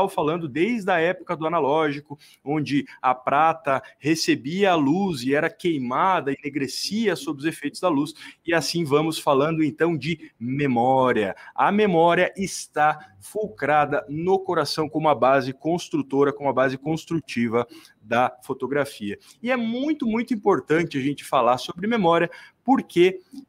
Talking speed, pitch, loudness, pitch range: 140 wpm, 160 Hz, -23 LUFS, 145-185 Hz